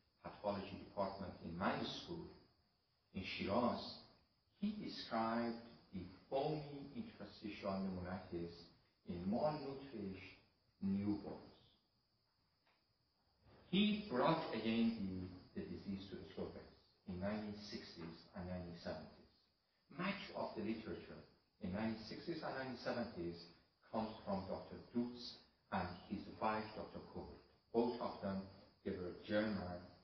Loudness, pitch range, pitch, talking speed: -45 LUFS, 90-115 Hz, 105 Hz, 105 wpm